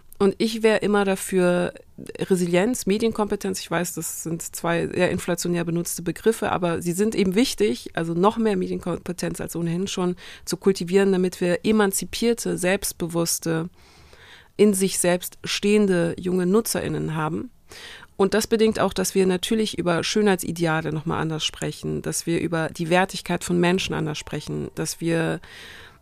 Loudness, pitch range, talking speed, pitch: -23 LUFS, 170-200 Hz, 150 wpm, 180 Hz